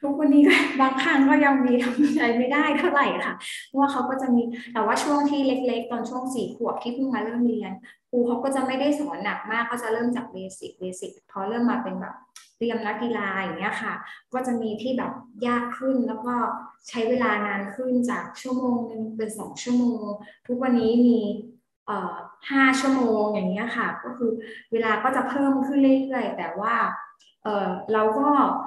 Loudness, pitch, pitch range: -24 LUFS, 240 Hz, 220-265 Hz